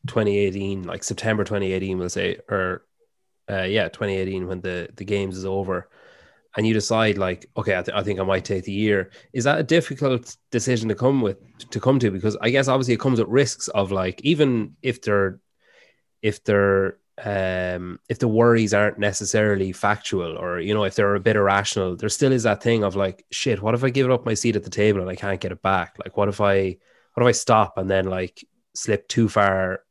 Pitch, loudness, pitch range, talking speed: 105 Hz, -22 LUFS, 95-115 Hz, 220 wpm